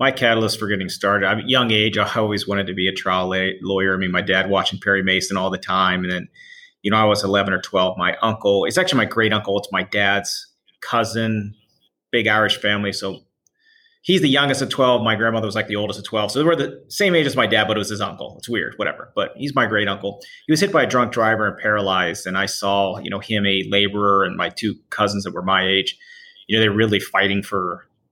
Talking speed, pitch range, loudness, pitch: 250 wpm, 95-115 Hz, -19 LUFS, 105 Hz